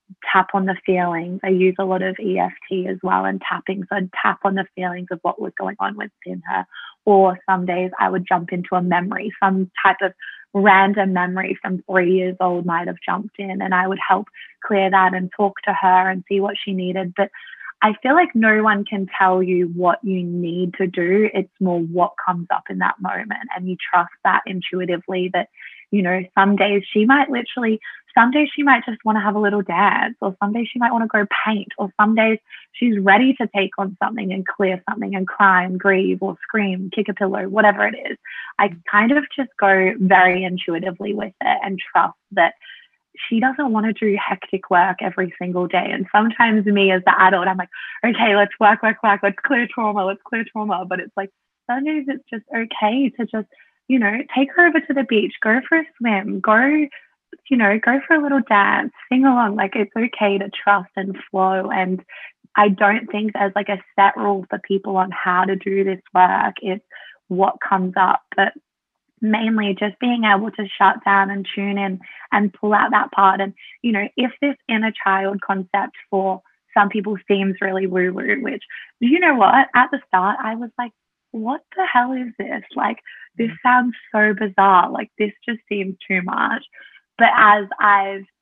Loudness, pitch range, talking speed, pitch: -18 LUFS, 190-225 Hz, 205 wpm, 200 Hz